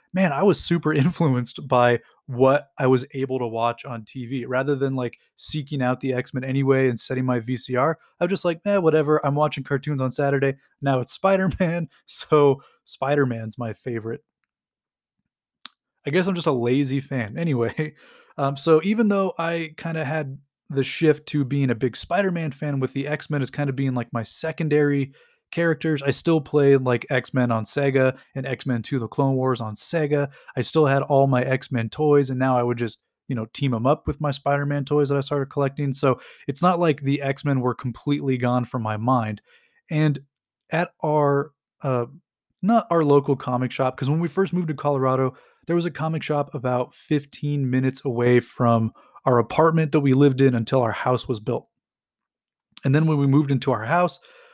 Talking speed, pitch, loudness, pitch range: 205 wpm, 140 Hz, -23 LUFS, 130-155 Hz